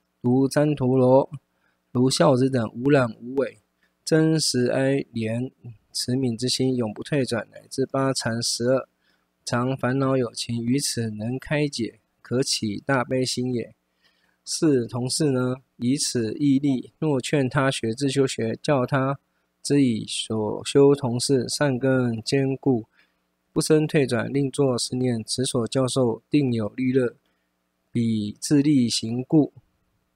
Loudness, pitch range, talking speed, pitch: -23 LUFS, 115-135 Hz, 185 characters per minute, 125 Hz